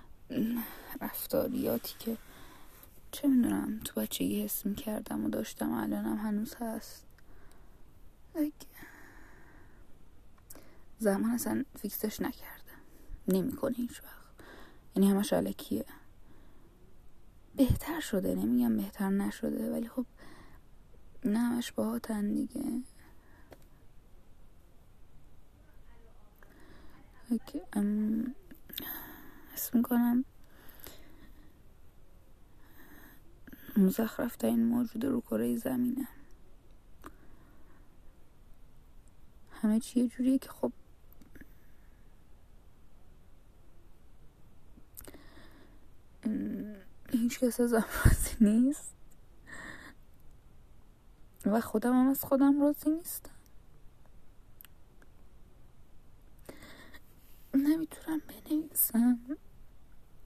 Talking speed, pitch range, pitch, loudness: 65 wpm, 220-270 Hz, 240 Hz, -32 LUFS